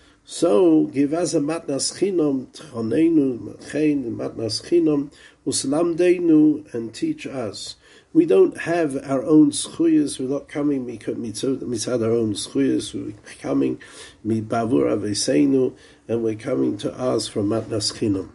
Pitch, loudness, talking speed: 145 Hz, -21 LUFS, 125 wpm